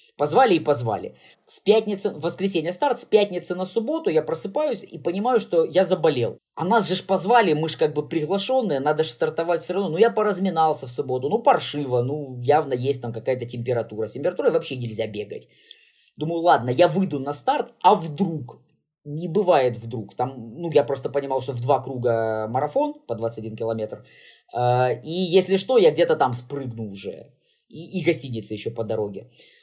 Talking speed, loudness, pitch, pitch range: 180 wpm, -23 LUFS, 160 Hz, 125-195 Hz